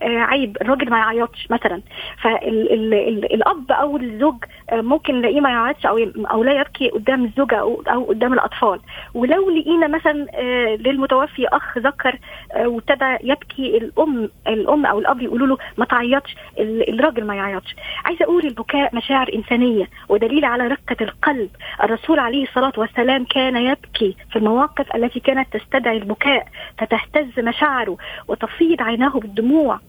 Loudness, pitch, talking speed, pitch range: -18 LUFS, 255 Hz, 150 wpm, 230-280 Hz